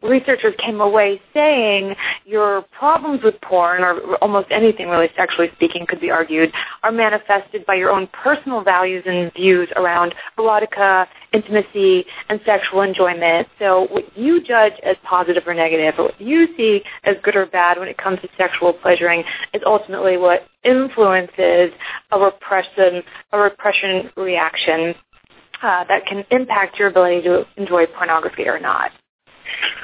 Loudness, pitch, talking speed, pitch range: -17 LUFS, 195 Hz, 150 wpm, 180-215 Hz